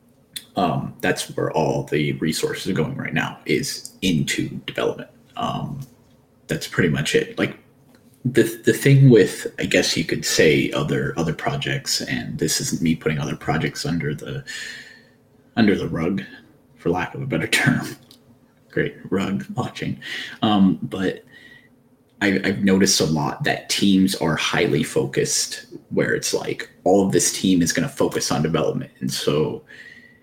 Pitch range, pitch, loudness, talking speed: 90-120 Hz, 100 Hz, -21 LUFS, 155 wpm